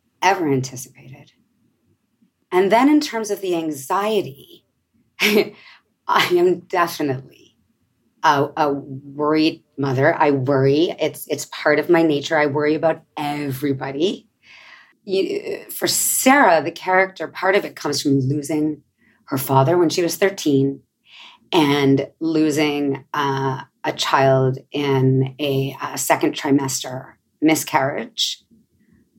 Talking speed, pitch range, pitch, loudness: 115 wpm, 135-170 Hz, 150 Hz, -19 LUFS